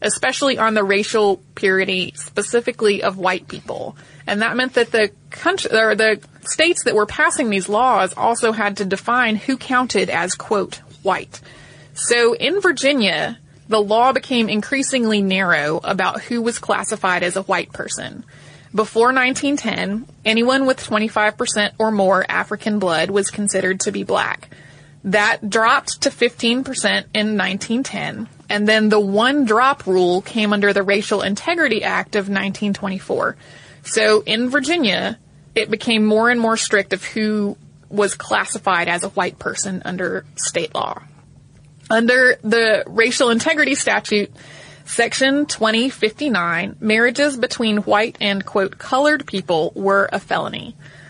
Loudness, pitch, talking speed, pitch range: -18 LUFS, 215 Hz, 140 wpm, 195-240 Hz